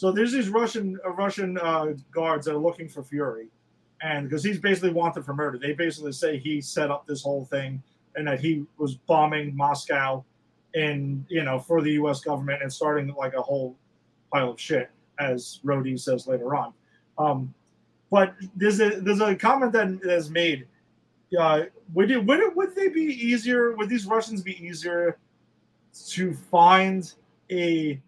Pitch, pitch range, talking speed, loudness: 160 Hz, 140-190 Hz, 175 wpm, -25 LUFS